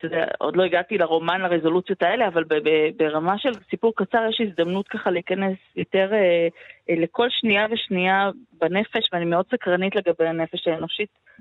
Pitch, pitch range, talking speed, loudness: 185 Hz, 170-210 Hz, 135 wpm, -22 LUFS